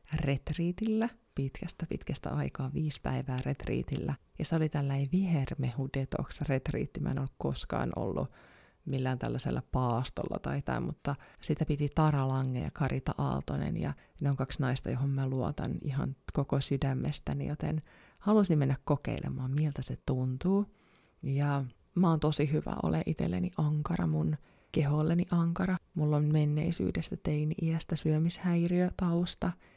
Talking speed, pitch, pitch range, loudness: 135 wpm, 145 Hz, 130-160 Hz, -33 LUFS